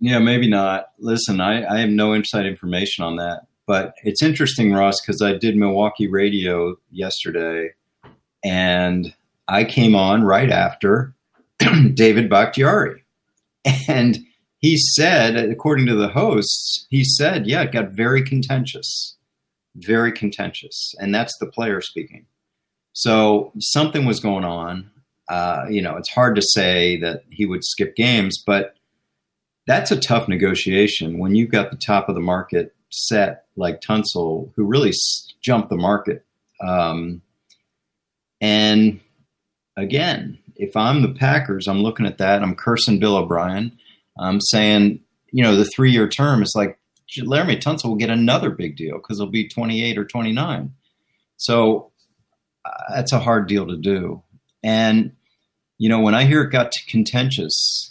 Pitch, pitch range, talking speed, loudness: 105 Hz, 100-115 Hz, 150 wpm, -18 LUFS